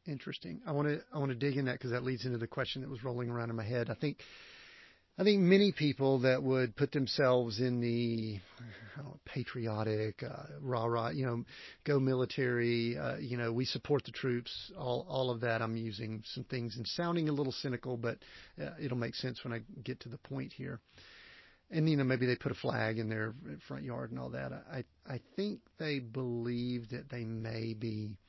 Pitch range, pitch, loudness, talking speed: 115-140 Hz, 125 Hz, -36 LUFS, 210 wpm